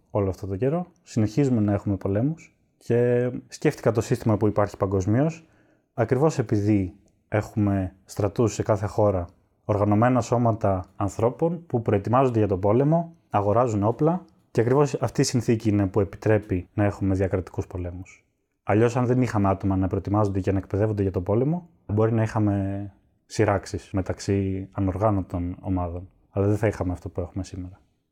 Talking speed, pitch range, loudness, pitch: 155 wpm, 95-120 Hz, -24 LUFS, 105 Hz